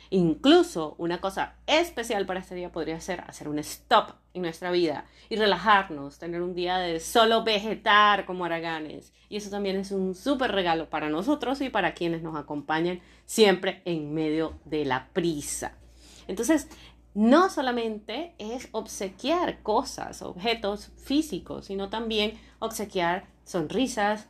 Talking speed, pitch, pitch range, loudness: 140 wpm, 195 Hz, 170-225 Hz, -27 LUFS